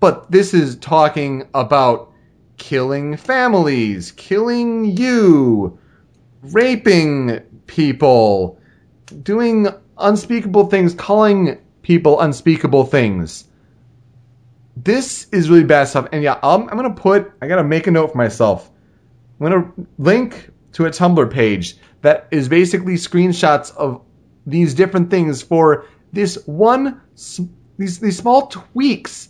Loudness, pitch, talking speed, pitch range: -15 LUFS, 170 Hz, 120 wpm, 135-200 Hz